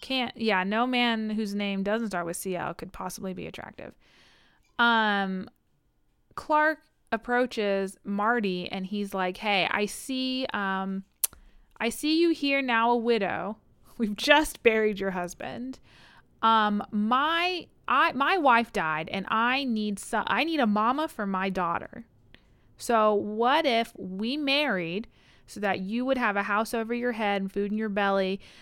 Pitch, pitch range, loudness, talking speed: 215 Hz, 195-245 Hz, -27 LUFS, 155 wpm